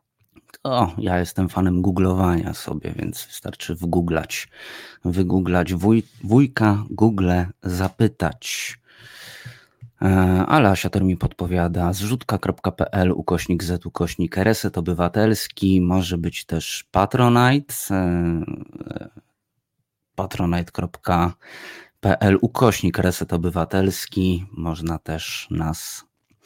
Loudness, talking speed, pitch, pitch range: -21 LUFS, 80 wpm, 95 Hz, 90-105 Hz